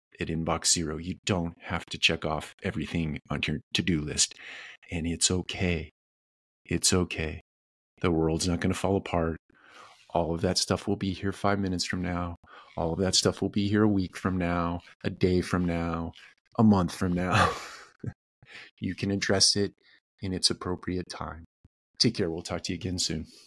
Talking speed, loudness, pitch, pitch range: 185 wpm, -28 LUFS, 90 Hz, 85-95 Hz